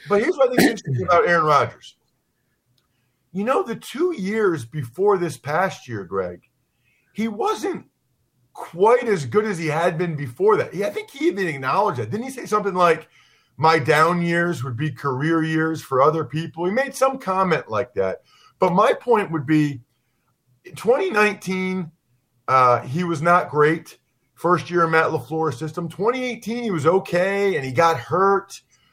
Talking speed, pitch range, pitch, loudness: 175 wpm, 150-205 Hz, 170 Hz, -21 LUFS